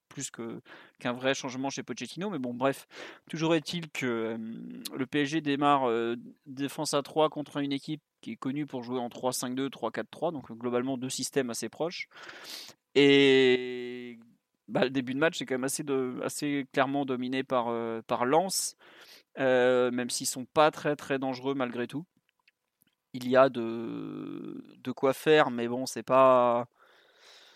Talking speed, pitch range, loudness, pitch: 170 wpm, 125-145 Hz, -29 LUFS, 135 Hz